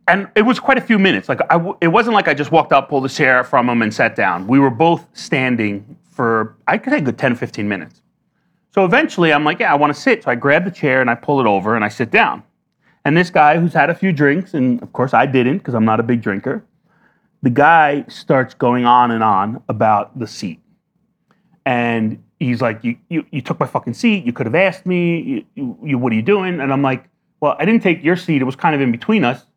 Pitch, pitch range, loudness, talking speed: 150 Hz, 125-185 Hz, -15 LUFS, 255 wpm